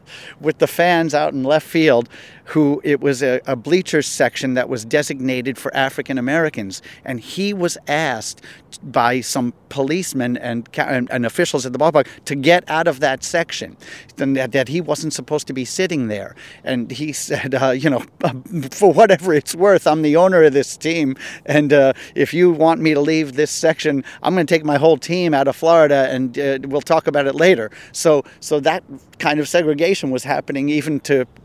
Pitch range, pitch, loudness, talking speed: 135-160 Hz, 150 Hz, -17 LUFS, 195 wpm